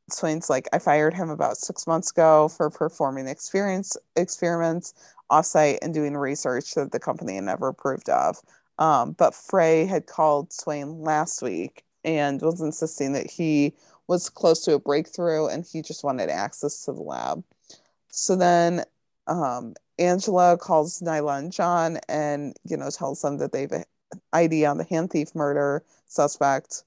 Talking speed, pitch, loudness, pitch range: 165 wpm, 155 Hz, -24 LUFS, 145-170 Hz